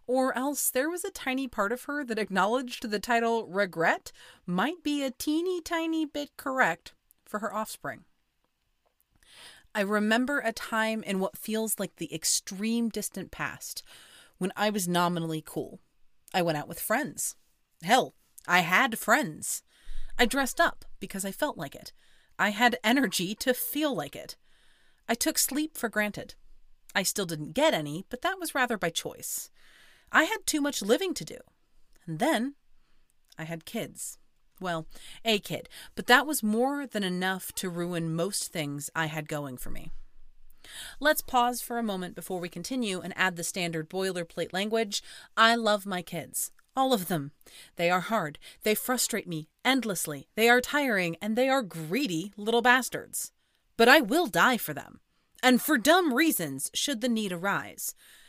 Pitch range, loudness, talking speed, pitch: 180-255 Hz, -28 LUFS, 165 wpm, 215 Hz